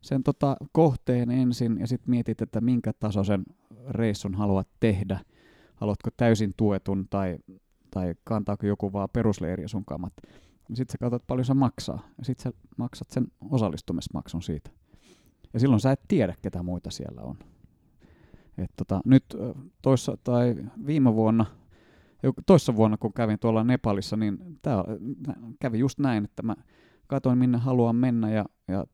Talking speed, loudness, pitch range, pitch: 150 wpm, -27 LUFS, 100-125 Hz, 115 Hz